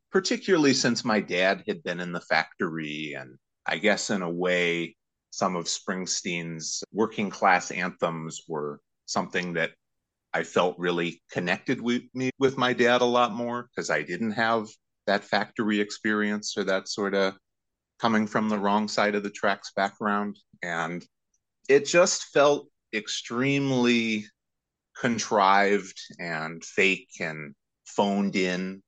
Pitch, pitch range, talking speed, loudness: 100 Hz, 85-120 Hz, 140 wpm, -26 LUFS